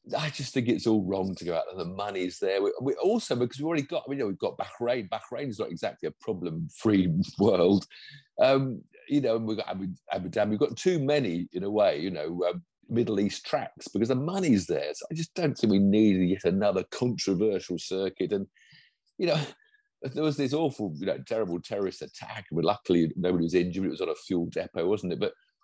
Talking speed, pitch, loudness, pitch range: 240 wpm, 115 Hz, -28 LUFS, 95-155 Hz